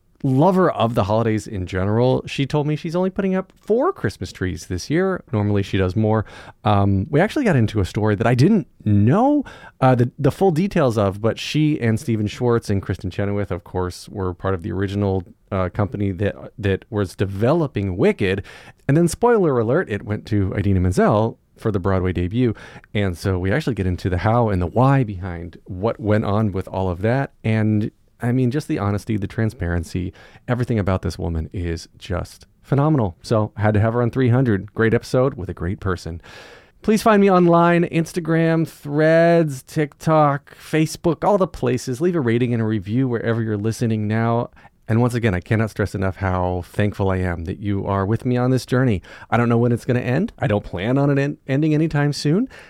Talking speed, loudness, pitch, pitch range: 205 wpm, -20 LUFS, 110 Hz, 100-140 Hz